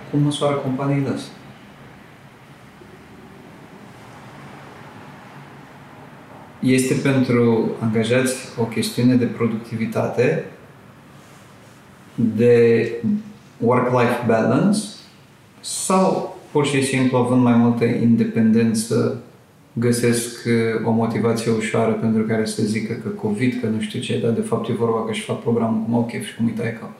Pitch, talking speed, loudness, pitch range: 115 Hz, 110 wpm, -20 LUFS, 115-130 Hz